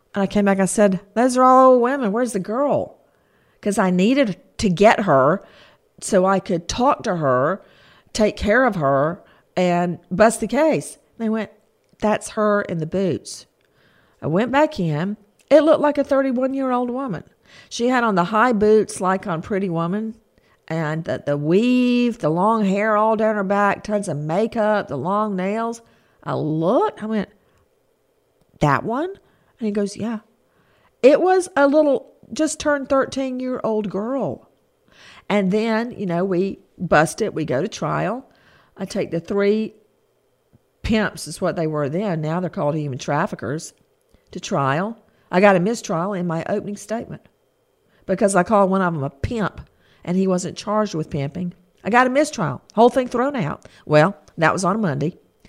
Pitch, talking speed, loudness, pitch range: 205 Hz, 175 wpm, -20 LUFS, 175-230 Hz